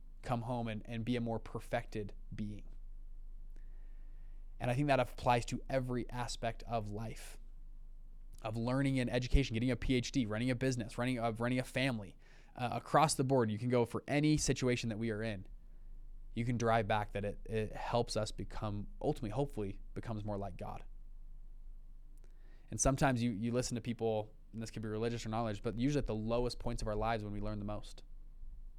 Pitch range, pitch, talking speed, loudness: 110-125 Hz, 115 Hz, 190 wpm, -37 LUFS